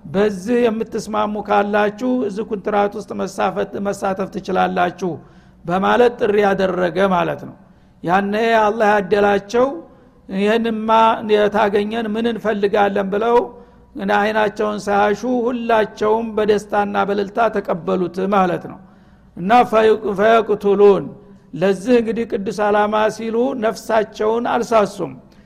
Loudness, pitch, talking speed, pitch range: -17 LUFS, 210 Hz, 90 wpm, 200-225 Hz